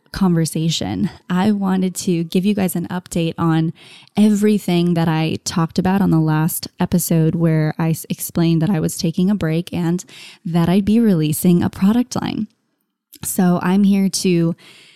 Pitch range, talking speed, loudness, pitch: 165-190 Hz, 160 wpm, -18 LUFS, 175 Hz